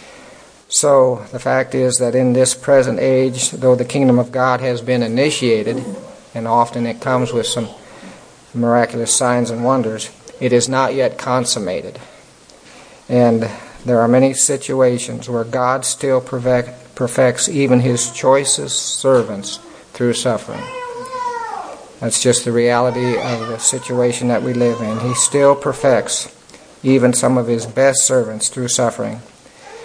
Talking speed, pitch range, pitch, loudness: 140 wpm, 120-130 Hz, 125 Hz, -16 LUFS